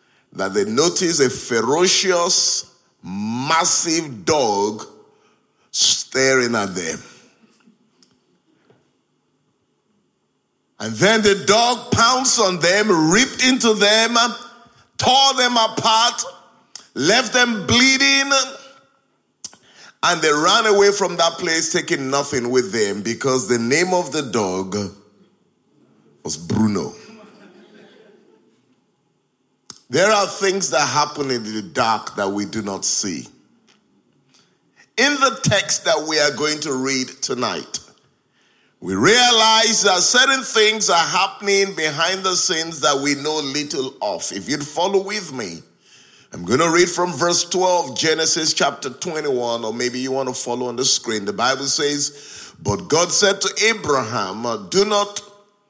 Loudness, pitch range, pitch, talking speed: -17 LUFS, 135-215 Hz, 175 Hz, 125 wpm